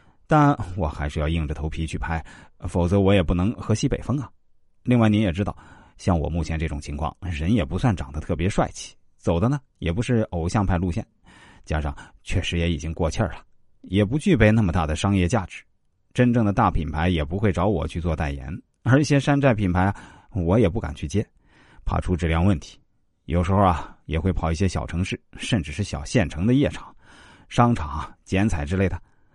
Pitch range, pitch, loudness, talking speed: 80-105 Hz, 90 Hz, -23 LUFS, 290 characters per minute